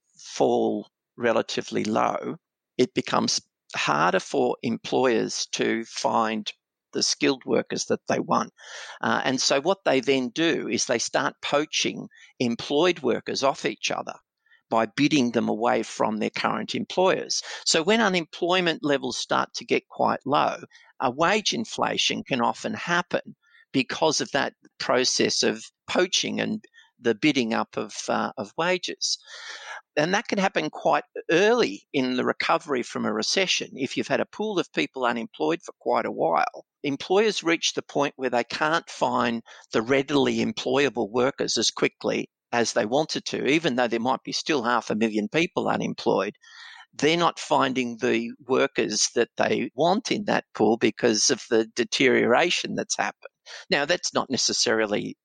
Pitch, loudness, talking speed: 145 Hz, -24 LUFS, 155 wpm